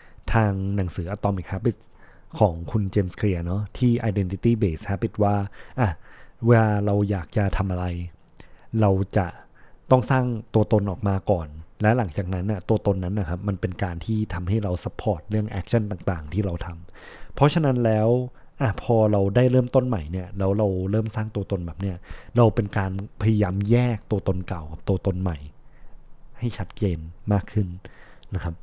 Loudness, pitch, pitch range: -24 LUFS, 100 Hz, 95-110 Hz